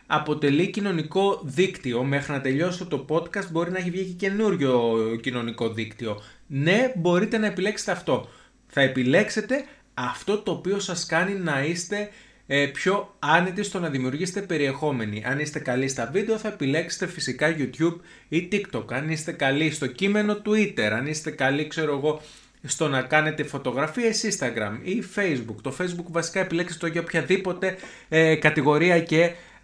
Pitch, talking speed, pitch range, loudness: 165 Hz, 150 wpm, 140-190 Hz, -25 LUFS